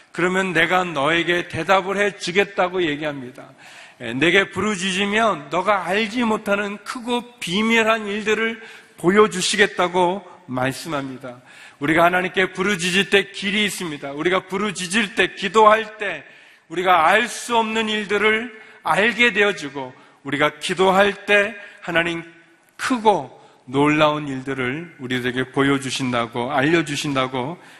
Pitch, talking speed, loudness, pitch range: 185 Hz, 290 characters per minute, -19 LUFS, 150-205 Hz